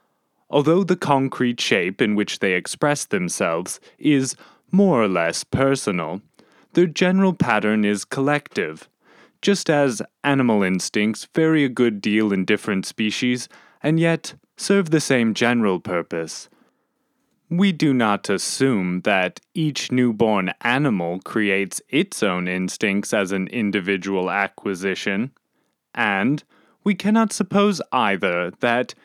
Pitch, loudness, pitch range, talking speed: 125 Hz, -21 LUFS, 100-160 Hz, 120 wpm